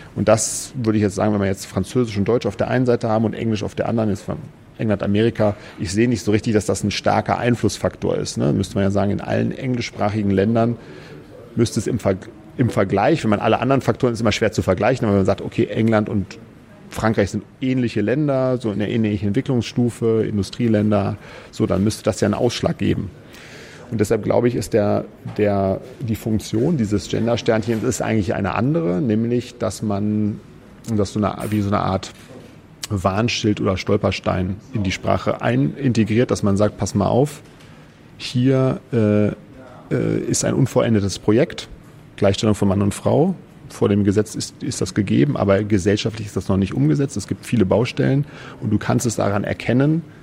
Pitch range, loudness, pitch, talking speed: 100-120 Hz, -20 LUFS, 110 Hz, 190 wpm